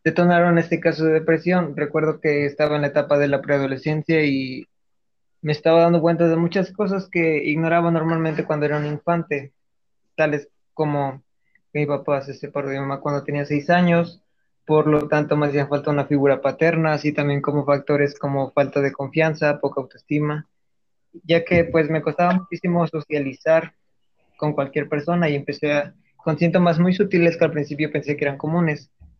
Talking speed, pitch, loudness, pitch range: 175 wpm, 150 Hz, -21 LUFS, 145-165 Hz